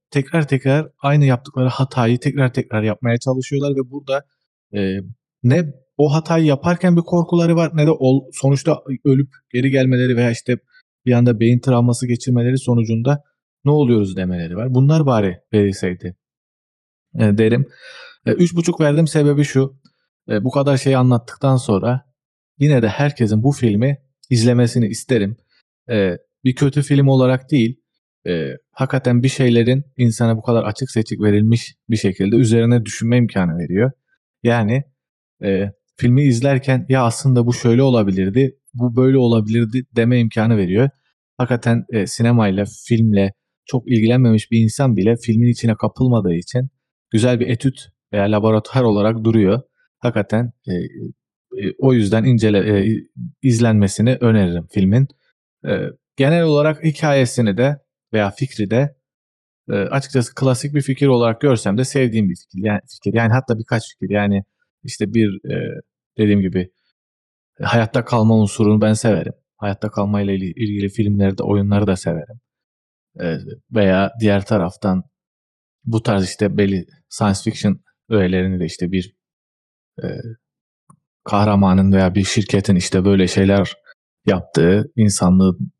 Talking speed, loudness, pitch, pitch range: 135 wpm, -17 LUFS, 120 Hz, 105-135 Hz